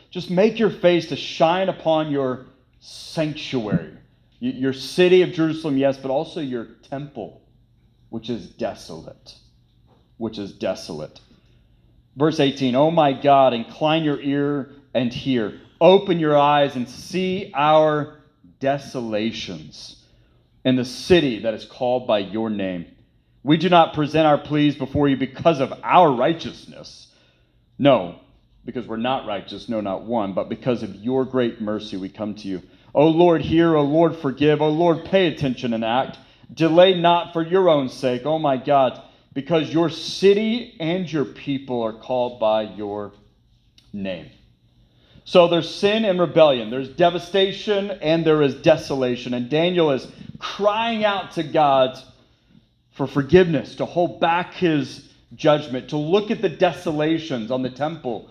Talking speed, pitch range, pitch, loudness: 155 wpm, 125-165 Hz, 140 Hz, -20 LUFS